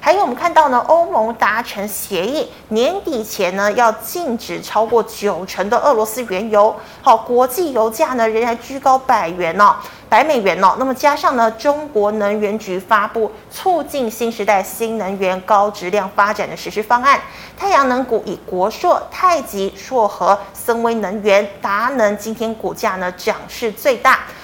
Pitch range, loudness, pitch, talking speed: 205-250 Hz, -16 LUFS, 220 Hz, 255 characters per minute